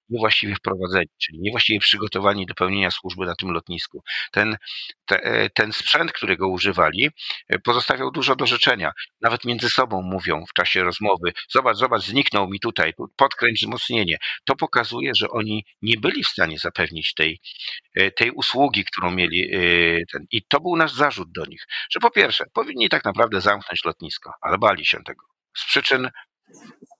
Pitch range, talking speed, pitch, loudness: 90-120 Hz, 160 wpm, 100 Hz, -20 LUFS